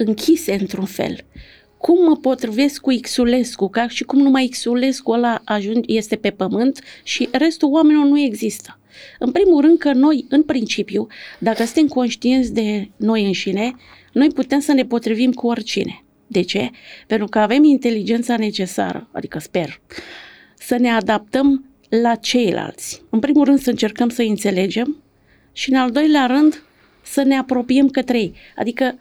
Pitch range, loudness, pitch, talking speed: 220-275 Hz, -17 LUFS, 245 Hz, 155 wpm